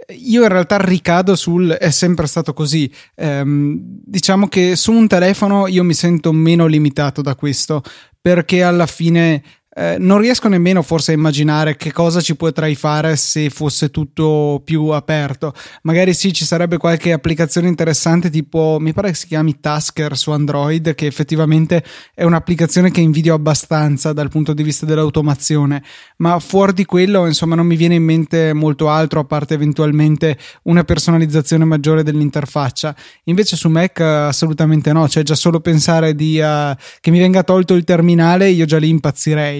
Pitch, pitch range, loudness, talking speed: 160 Hz, 155-175 Hz, -14 LUFS, 165 wpm